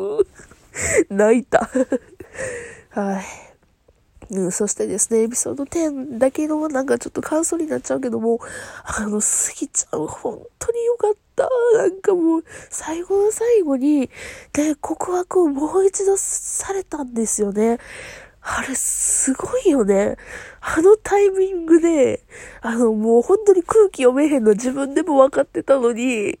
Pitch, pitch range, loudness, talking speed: 310 Hz, 240-395 Hz, -19 LUFS, 275 characters per minute